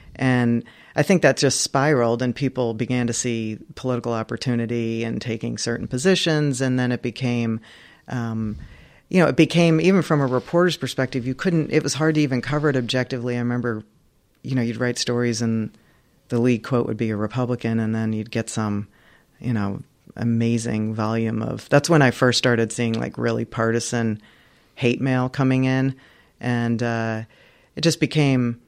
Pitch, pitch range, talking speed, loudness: 120 Hz, 115-130 Hz, 175 wpm, -22 LUFS